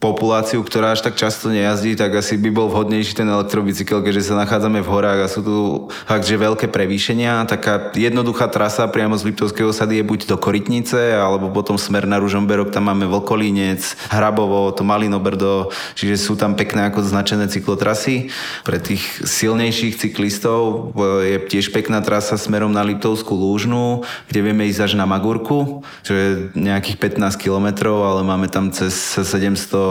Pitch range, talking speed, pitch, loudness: 100-110 Hz, 165 wpm, 105 Hz, -17 LUFS